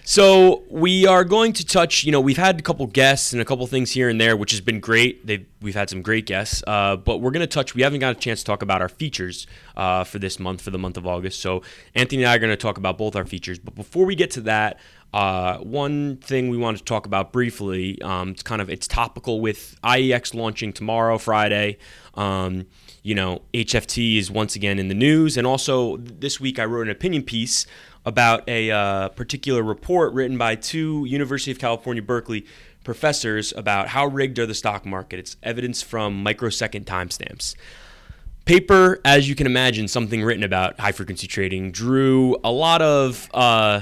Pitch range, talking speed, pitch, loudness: 100-130 Hz, 205 wpm, 115 Hz, -20 LUFS